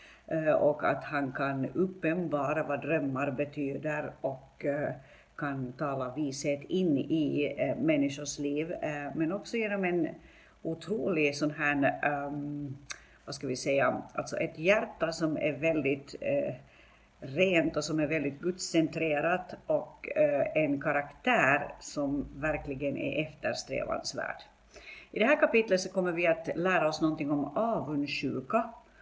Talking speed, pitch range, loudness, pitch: 120 wpm, 145-185 Hz, -31 LUFS, 155 Hz